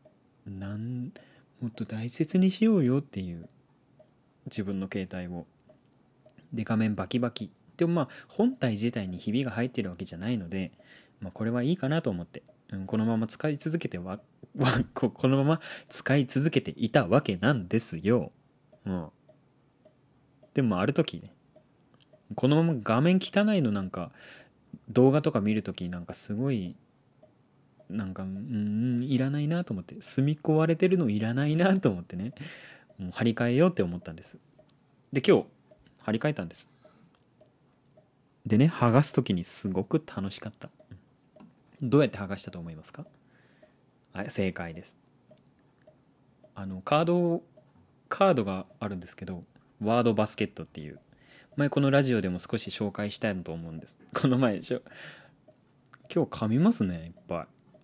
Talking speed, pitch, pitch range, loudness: 300 characters per minute, 120 Hz, 100-145 Hz, -28 LUFS